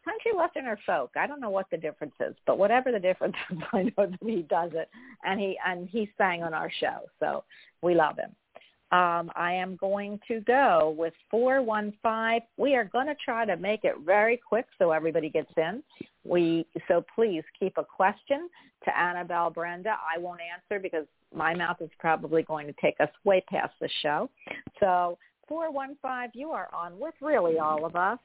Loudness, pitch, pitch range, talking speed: -28 LUFS, 190 Hz, 170-235 Hz, 200 wpm